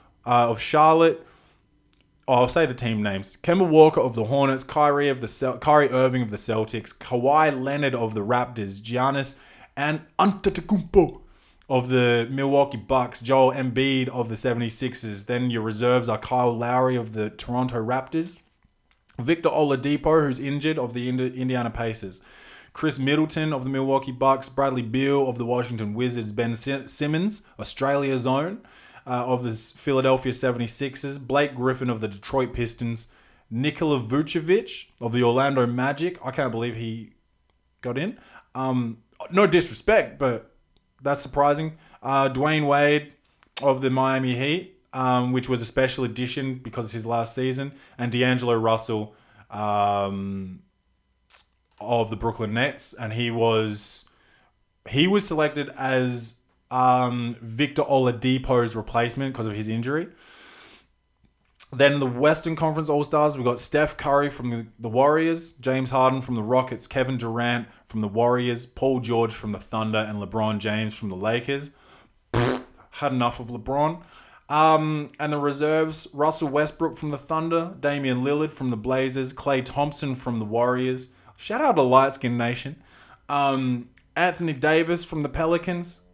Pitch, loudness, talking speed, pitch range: 130 Hz, -23 LUFS, 145 wpm, 115-145 Hz